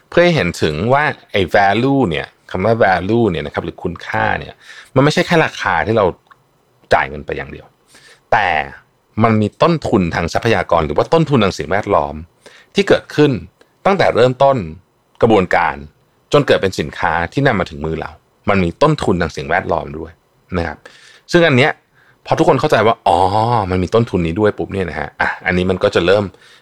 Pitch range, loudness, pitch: 85-125 Hz, -15 LUFS, 105 Hz